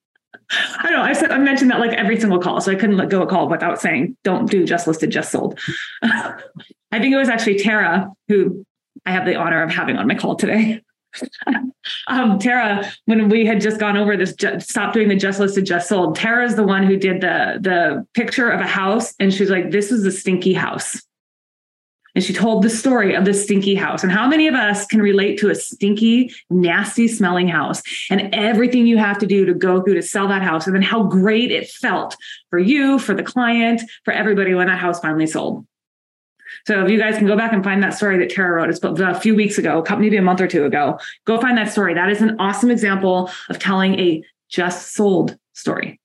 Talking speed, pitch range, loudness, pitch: 230 wpm, 185-225 Hz, -17 LUFS, 200 Hz